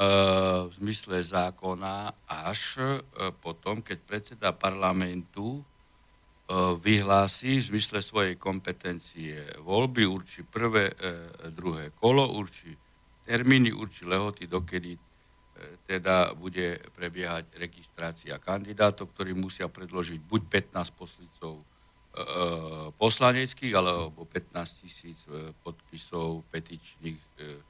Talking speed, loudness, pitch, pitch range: 85 wpm, -29 LUFS, 90 Hz, 85-100 Hz